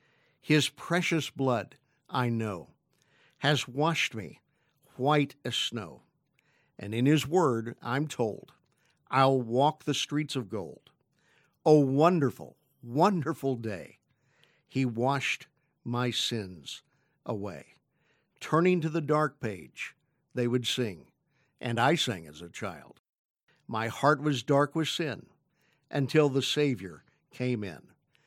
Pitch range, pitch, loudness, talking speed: 120-150 Hz, 135 Hz, -29 LUFS, 120 wpm